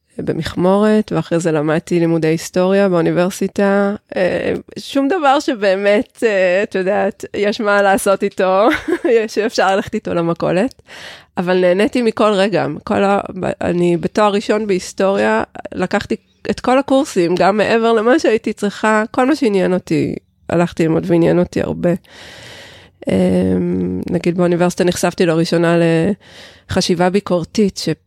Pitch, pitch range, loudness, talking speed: 190 Hz, 175-210 Hz, -16 LUFS, 120 wpm